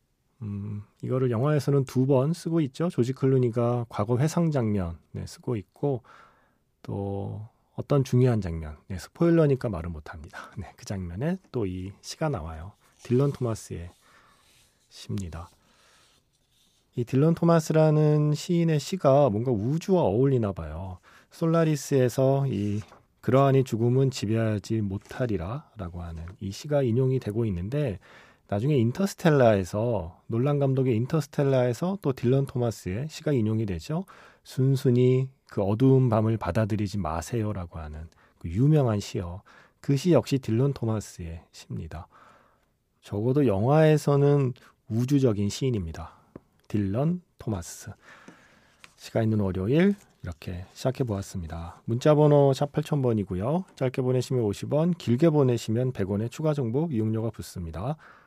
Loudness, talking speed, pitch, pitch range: -26 LUFS, 300 characters per minute, 125 Hz, 100-140 Hz